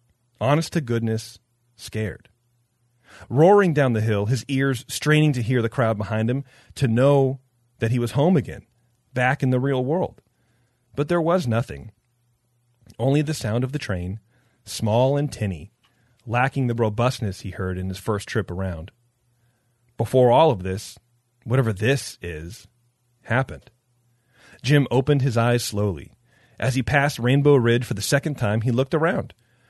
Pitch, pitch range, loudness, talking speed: 120 Hz, 115-130 Hz, -22 LUFS, 155 wpm